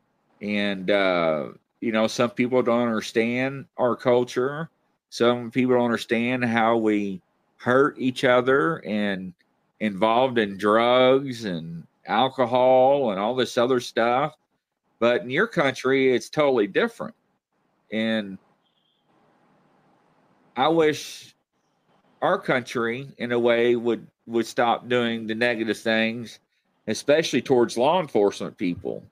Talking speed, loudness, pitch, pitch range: 115 wpm, -23 LUFS, 120 Hz, 110-130 Hz